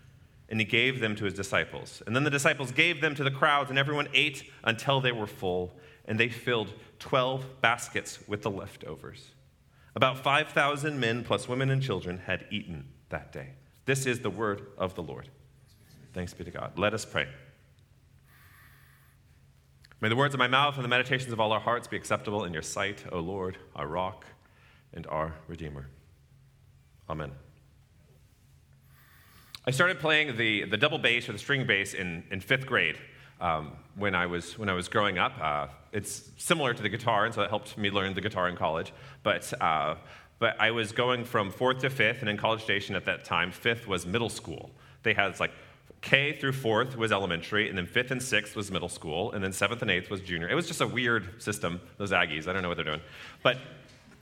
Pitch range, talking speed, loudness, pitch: 90-125 Hz, 200 wpm, -29 LUFS, 105 Hz